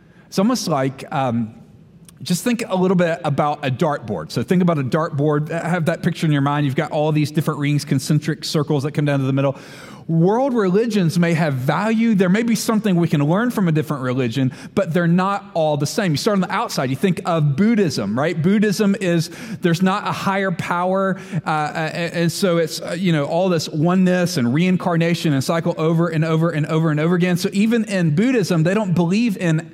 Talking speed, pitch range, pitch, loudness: 215 wpm, 155-190 Hz, 170 Hz, -19 LUFS